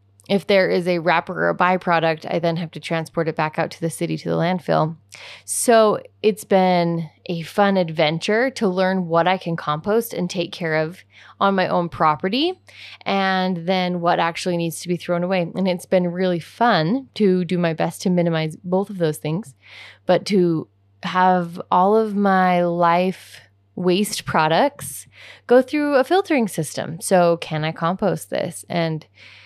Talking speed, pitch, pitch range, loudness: 175 wpm, 175 Hz, 160-190 Hz, -20 LUFS